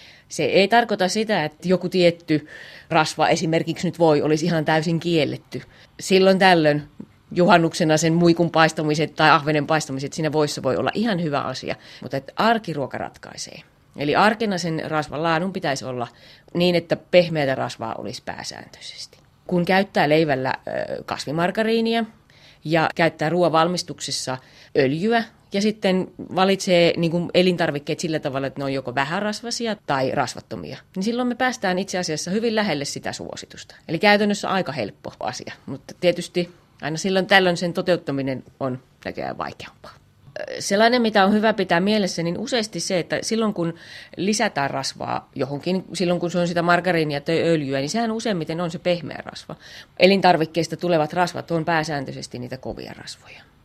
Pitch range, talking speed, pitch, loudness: 150-190 Hz, 150 wpm, 170 Hz, -21 LUFS